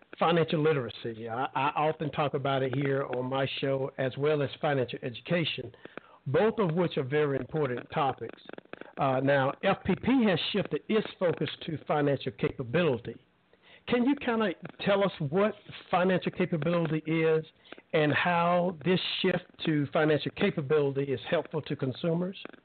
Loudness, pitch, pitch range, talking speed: -29 LUFS, 155 Hz, 140-180 Hz, 145 wpm